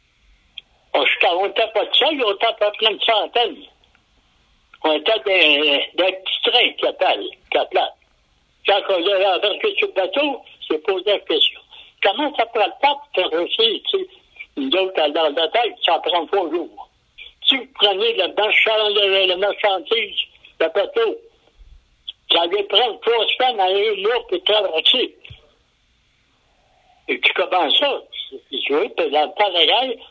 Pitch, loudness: 240 Hz, -18 LUFS